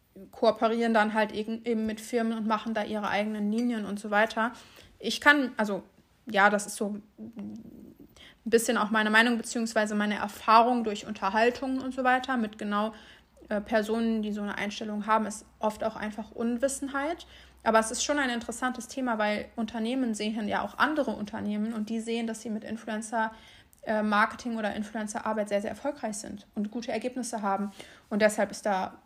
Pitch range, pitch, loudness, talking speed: 210-235 Hz, 220 Hz, -28 LUFS, 175 wpm